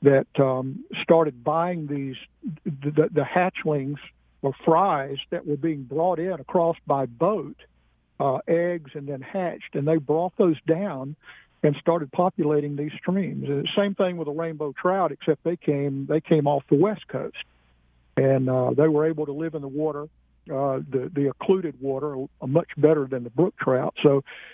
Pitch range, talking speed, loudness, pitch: 140-170 Hz, 175 wpm, -24 LUFS, 150 Hz